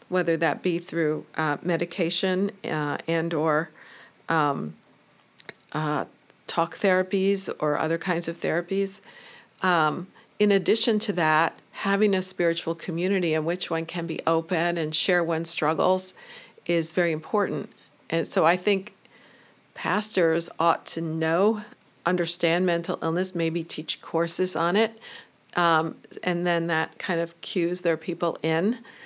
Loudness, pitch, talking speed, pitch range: -25 LUFS, 170 Hz, 135 wpm, 165-190 Hz